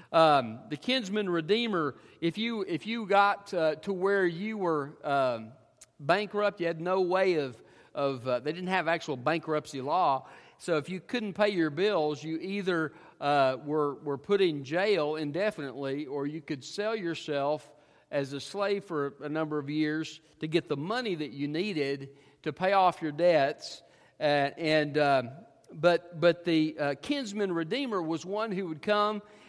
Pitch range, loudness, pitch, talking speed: 150-195 Hz, -30 LUFS, 160 Hz, 170 wpm